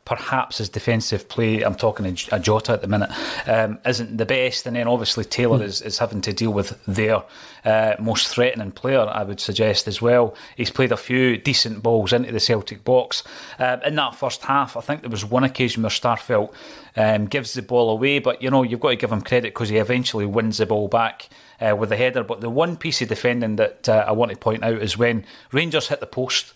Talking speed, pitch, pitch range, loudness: 235 wpm, 115 Hz, 110-125 Hz, -21 LUFS